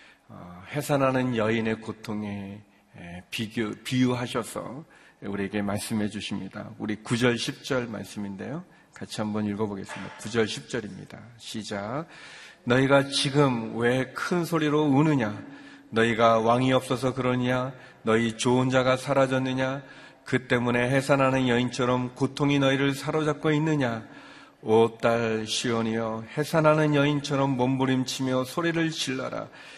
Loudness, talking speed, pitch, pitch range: -26 LUFS, 285 characters per minute, 125 Hz, 110-135 Hz